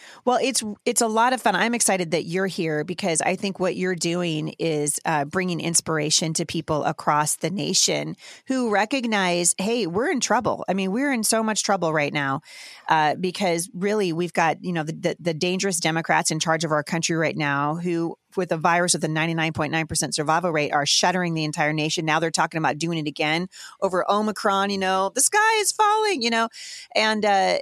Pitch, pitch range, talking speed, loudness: 175 Hz, 160-200 Hz, 215 wpm, -22 LUFS